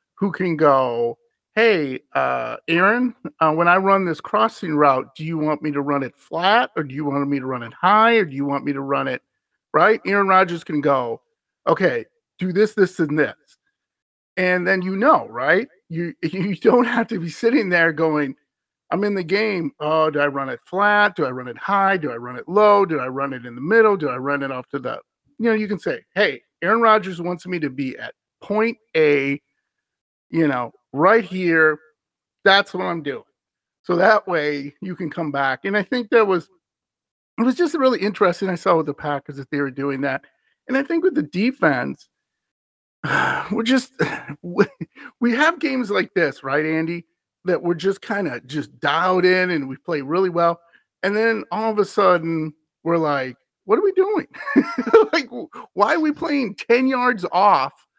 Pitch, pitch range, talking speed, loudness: 180 Hz, 150-220 Hz, 205 wpm, -20 LUFS